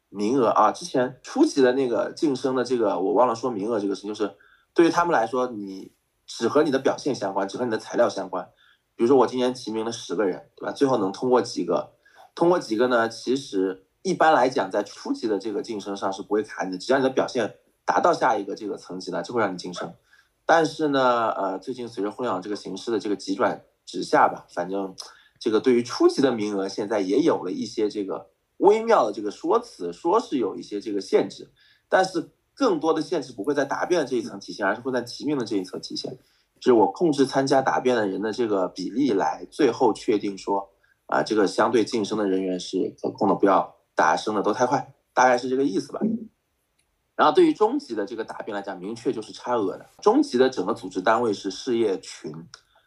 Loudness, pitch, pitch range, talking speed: -24 LUFS, 125 Hz, 100-140 Hz, 335 characters per minute